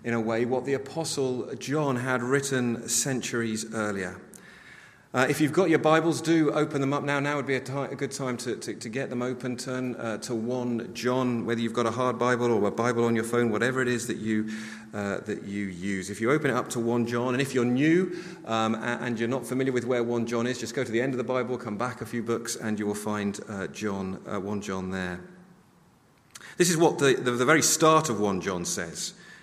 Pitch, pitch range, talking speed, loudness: 120 Hz, 115-135 Hz, 245 wpm, -27 LUFS